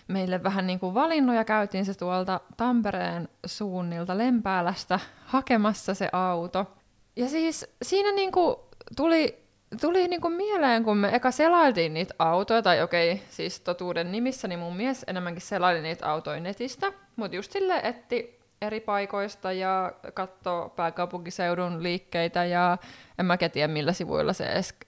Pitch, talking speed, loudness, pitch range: 190 Hz, 140 wpm, -27 LUFS, 175-245 Hz